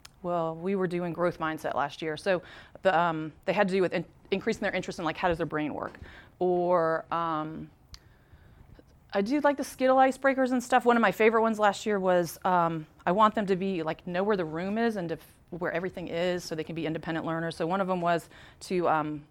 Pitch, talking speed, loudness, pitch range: 180 Hz, 235 wpm, -28 LUFS, 165-200 Hz